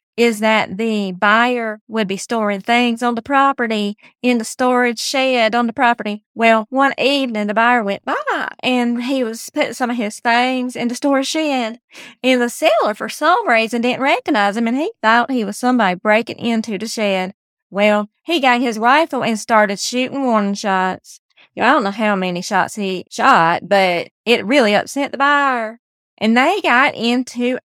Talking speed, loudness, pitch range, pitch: 185 wpm, -16 LUFS, 215-255 Hz, 235 Hz